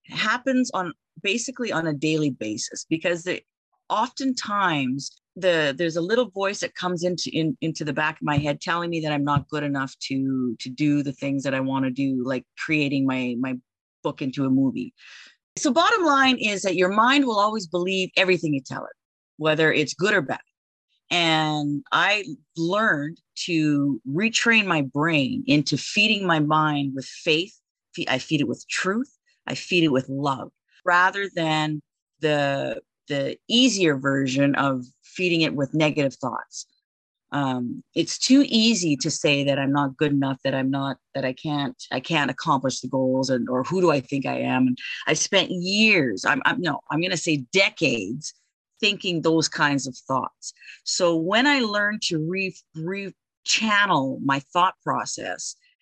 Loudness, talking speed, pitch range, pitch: -23 LUFS, 170 wpm, 135-185 Hz, 155 Hz